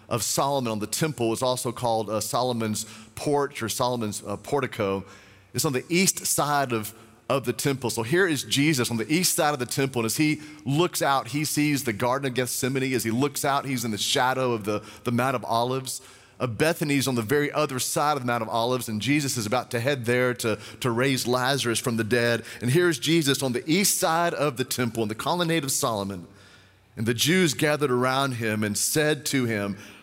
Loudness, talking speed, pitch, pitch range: -25 LUFS, 220 wpm, 125 Hz, 115-145 Hz